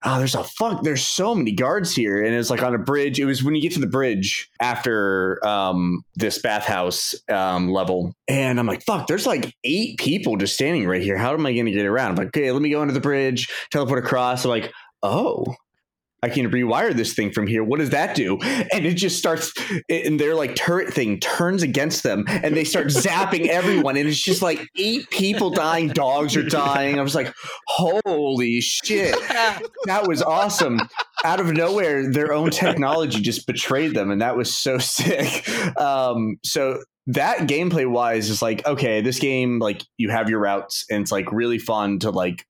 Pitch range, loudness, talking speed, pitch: 110-155 Hz, -21 LUFS, 200 wpm, 130 Hz